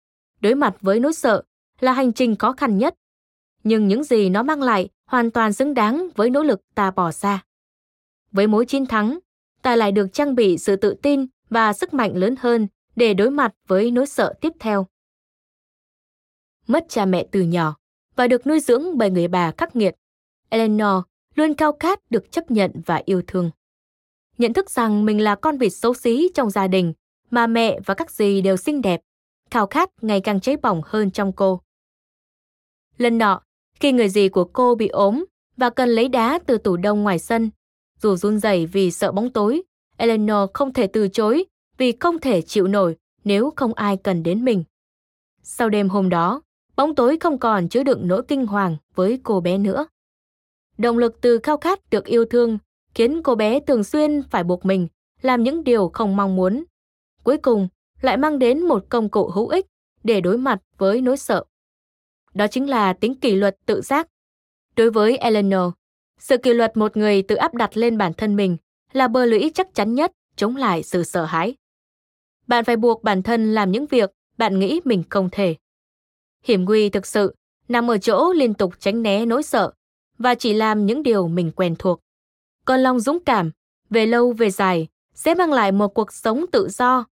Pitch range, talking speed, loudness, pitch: 195-255 Hz, 195 wpm, -19 LUFS, 225 Hz